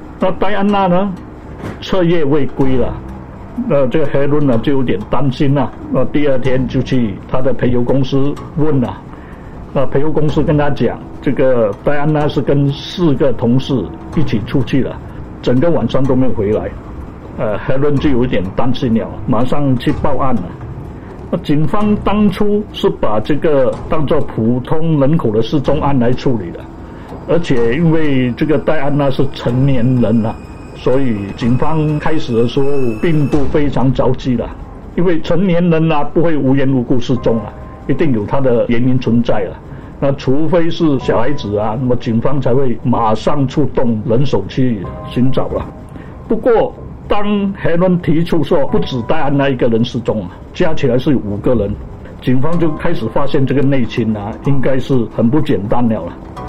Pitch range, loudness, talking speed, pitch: 120-155 Hz, -15 LUFS, 245 characters per minute, 135 Hz